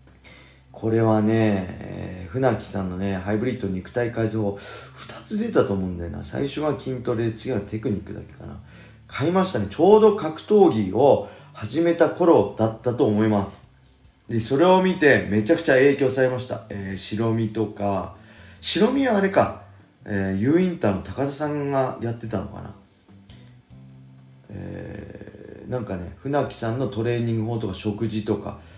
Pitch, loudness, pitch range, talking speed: 110 Hz, -22 LUFS, 100-130 Hz, 315 characters per minute